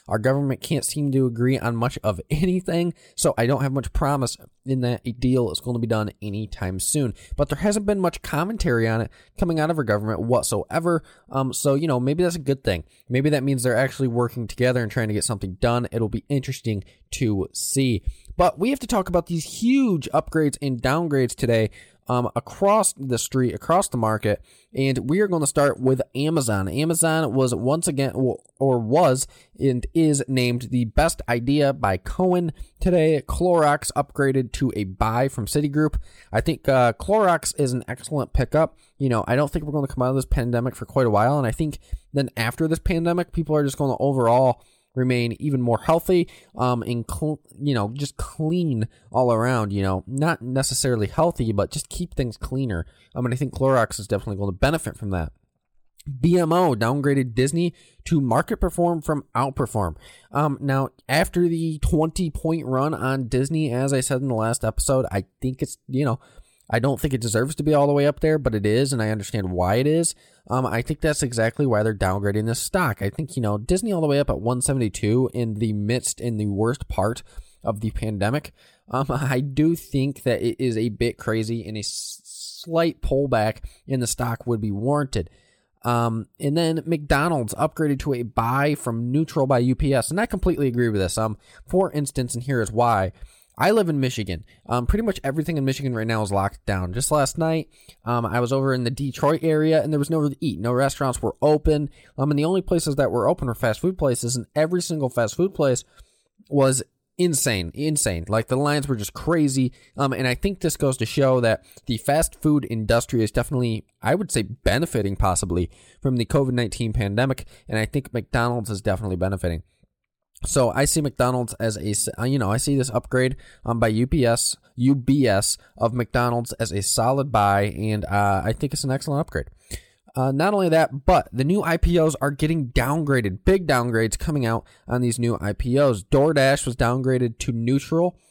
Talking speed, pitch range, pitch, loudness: 205 wpm, 115-150 Hz, 130 Hz, -23 LUFS